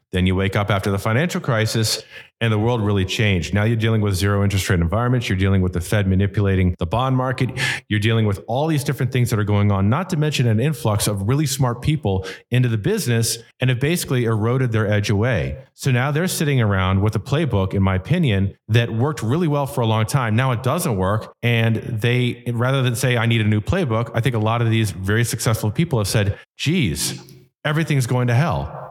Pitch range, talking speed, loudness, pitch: 105-130 Hz, 225 wpm, -20 LUFS, 115 Hz